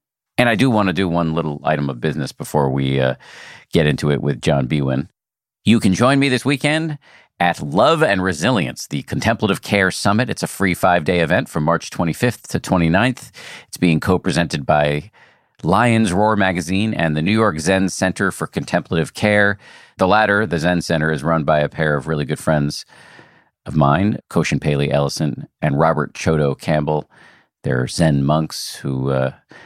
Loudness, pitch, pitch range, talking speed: -18 LUFS, 80 Hz, 75-100 Hz, 180 wpm